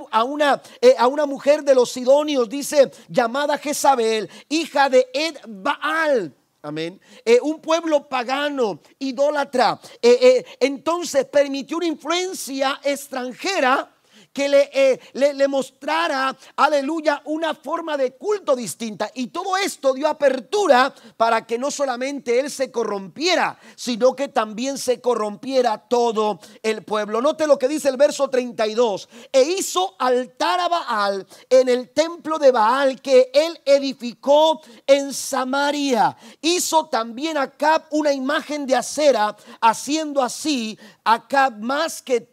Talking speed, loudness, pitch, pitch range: 140 wpm, -20 LUFS, 275 Hz, 245-300 Hz